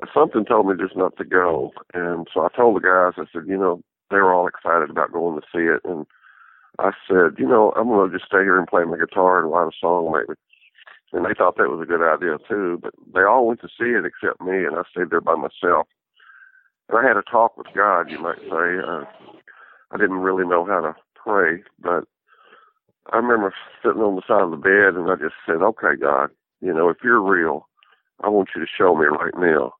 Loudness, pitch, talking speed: -19 LUFS, 95 Hz, 235 wpm